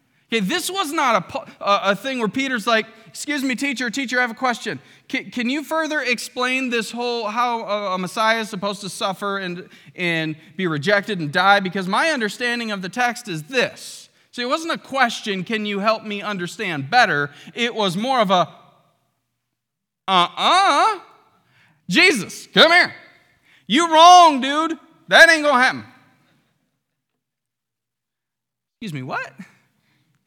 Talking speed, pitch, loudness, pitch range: 155 wpm, 220 Hz, -18 LUFS, 190-260 Hz